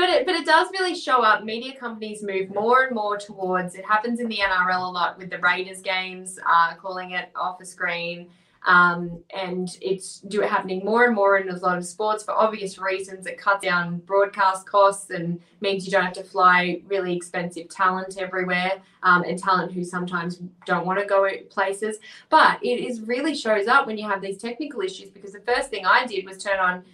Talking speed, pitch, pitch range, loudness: 215 wpm, 190 Hz, 180-210 Hz, -22 LUFS